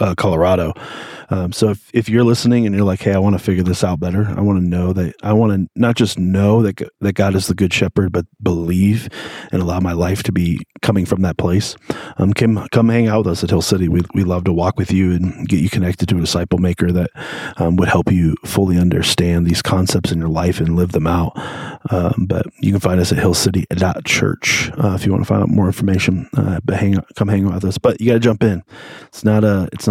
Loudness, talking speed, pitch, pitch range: -16 LUFS, 255 wpm, 95 Hz, 90-105 Hz